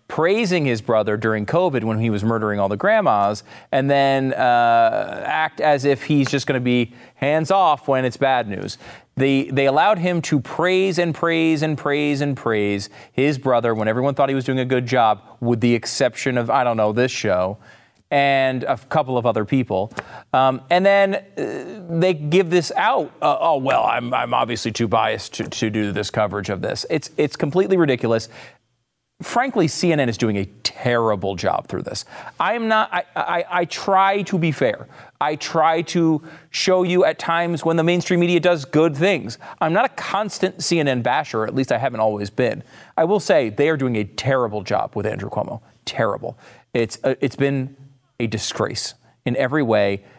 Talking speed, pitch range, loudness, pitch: 190 wpm, 115-165 Hz, -20 LUFS, 135 Hz